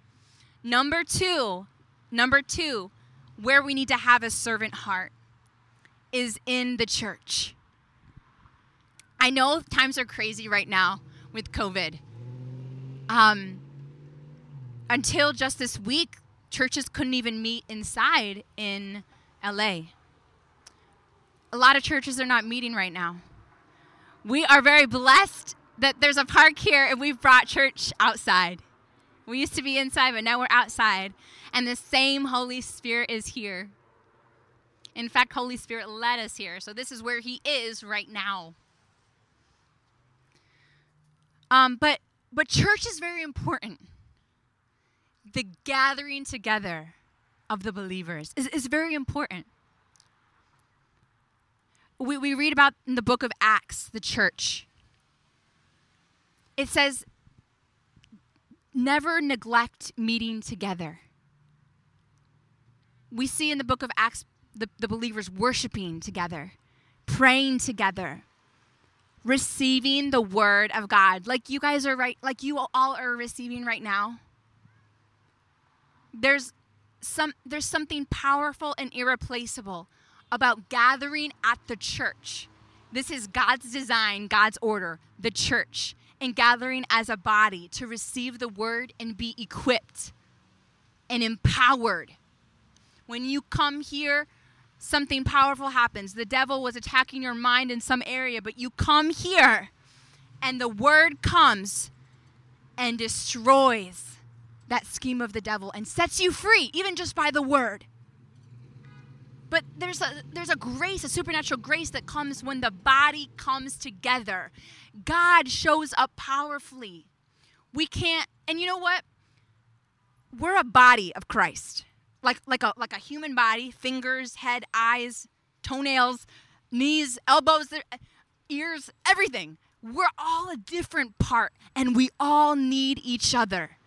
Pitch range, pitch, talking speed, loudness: 165-270 Hz, 235 Hz, 130 wpm, -24 LUFS